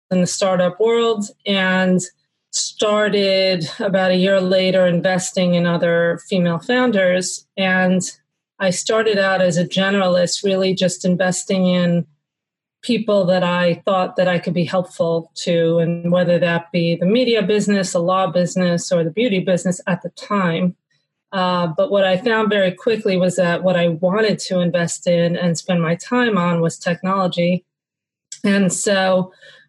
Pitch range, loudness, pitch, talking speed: 175-195 Hz, -18 LUFS, 185 Hz, 155 wpm